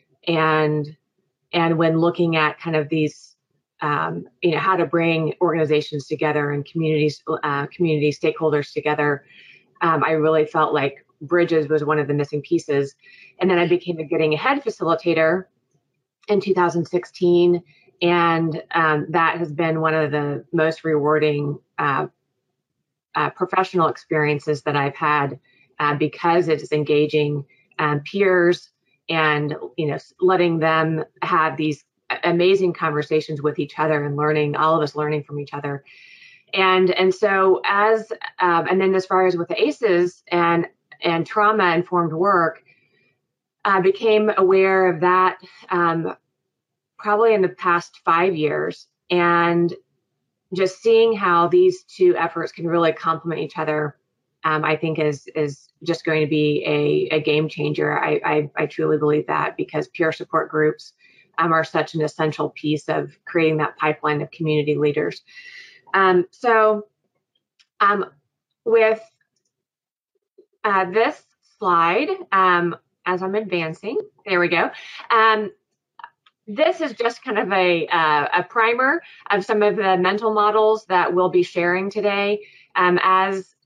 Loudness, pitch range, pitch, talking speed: -20 LUFS, 150-190 Hz, 170 Hz, 145 wpm